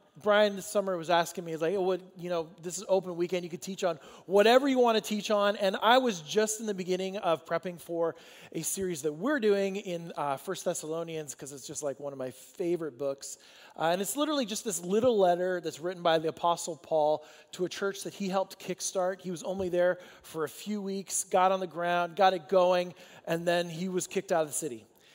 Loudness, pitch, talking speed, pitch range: -30 LUFS, 180 Hz, 235 wpm, 165-195 Hz